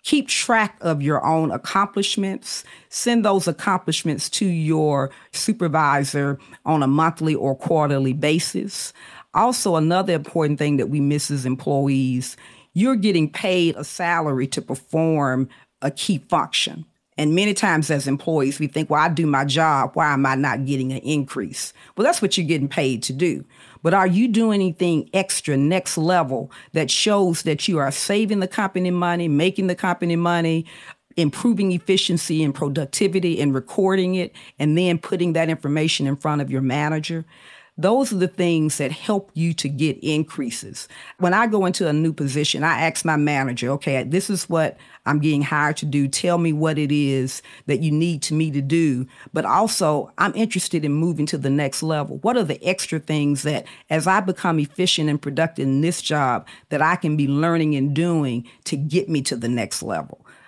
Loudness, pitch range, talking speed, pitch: -21 LUFS, 145-180 Hz, 180 wpm, 160 Hz